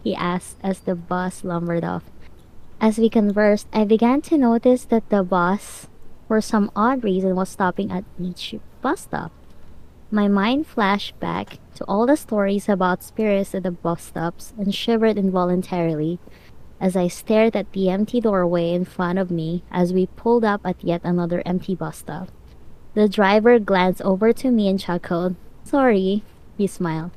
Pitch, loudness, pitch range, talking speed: 195 Hz, -21 LUFS, 180-215 Hz, 170 wpm